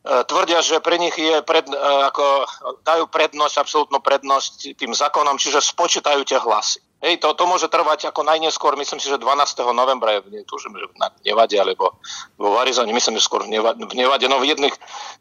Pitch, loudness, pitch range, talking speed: 155 Hz, -18 LUFS, 140-165 Hz, 205 wpm